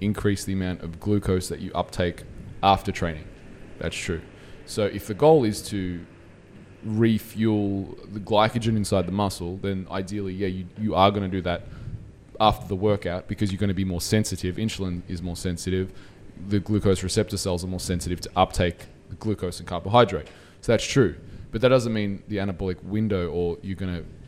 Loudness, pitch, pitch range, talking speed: -25 LUFS, 95 Hz, 90-105 Hz, 185 wpm